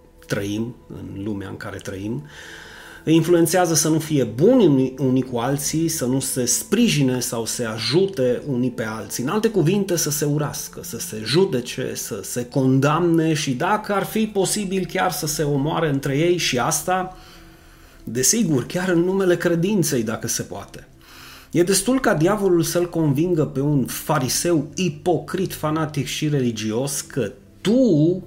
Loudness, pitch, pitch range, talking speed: -20 LUFS, 150 Hz, 125-175 Hz, 155 wpm